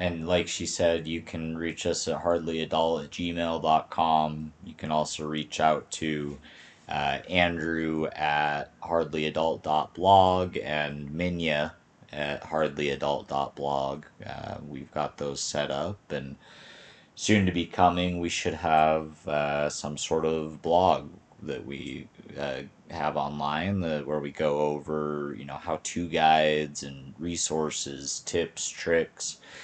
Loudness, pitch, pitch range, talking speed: -28 LUFS, 80 Hz, 75-85 Hz, 130 wpm